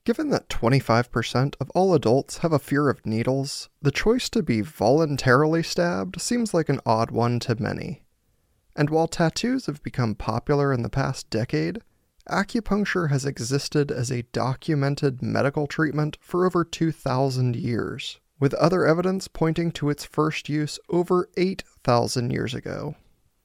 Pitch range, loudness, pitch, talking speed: 125-165 Hz, -24 LUFS, 145 Hz, 150 wpm